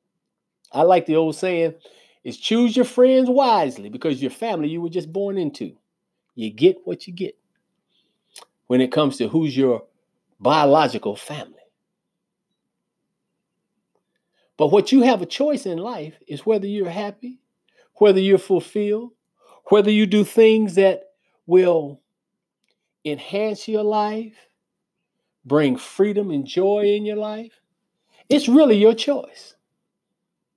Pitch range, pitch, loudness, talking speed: 170-220 Hz, 200 Hz, -19 LUFS, 130 wpm